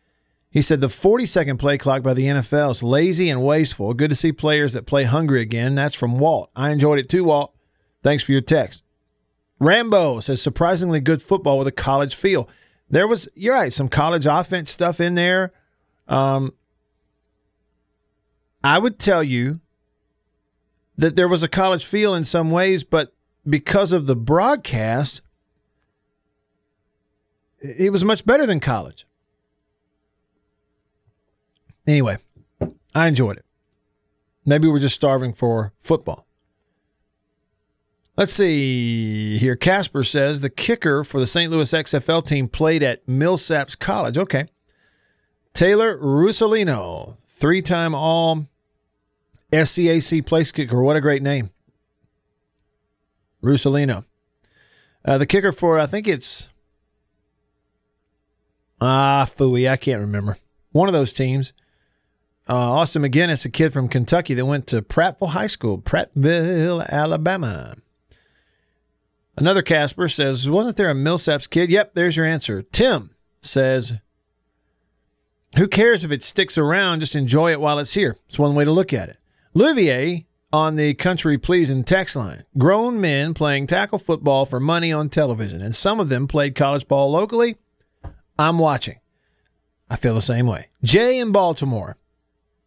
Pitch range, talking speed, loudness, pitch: 125-170 Hz, 140 wpm, -19 LUFS, 145 Hz